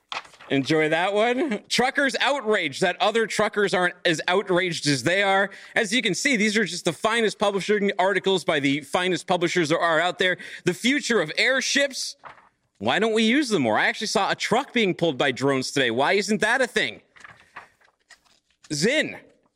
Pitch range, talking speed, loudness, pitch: 175-225 Hz, 180 wpm, -22 LUFS, 195 Hz